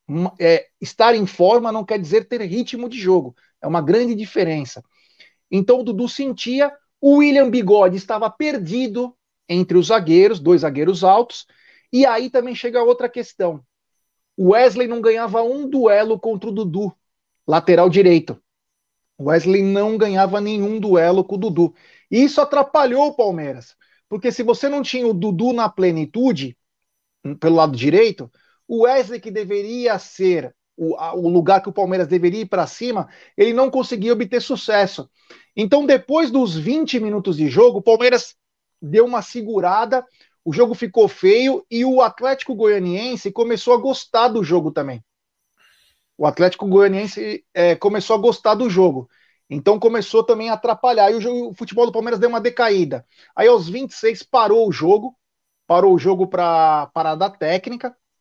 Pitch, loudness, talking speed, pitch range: 220 Hz, -17 LUFS, 160 wpm, 185-245 Hz